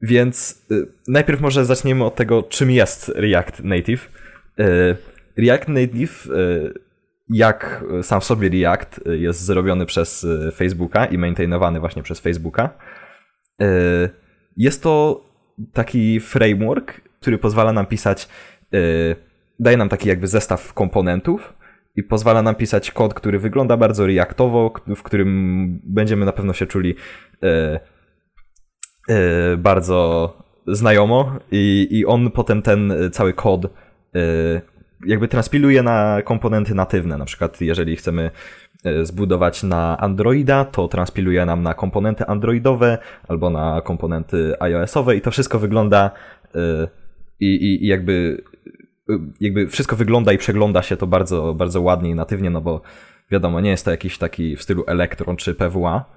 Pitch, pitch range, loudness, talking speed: 100 Hz, 85-115 Hz, -18 LUFS, 130 wpm